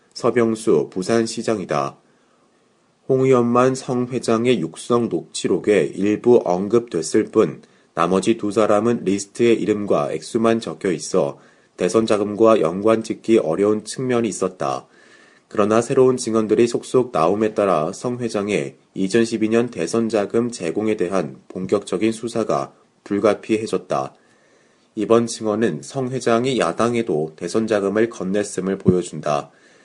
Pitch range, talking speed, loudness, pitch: 100-115 Hz, 280 characters per minute, -20 LUFS, 110 Hz